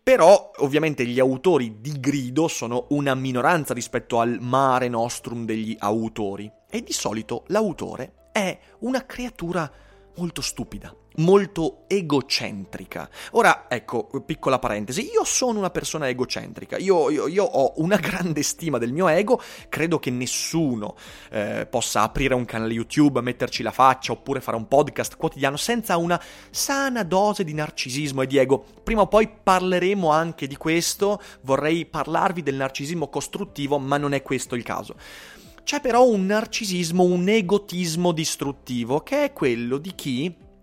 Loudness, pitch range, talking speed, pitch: -23 LUFS, 125-185 Hz, 150 wpm, 145 Hz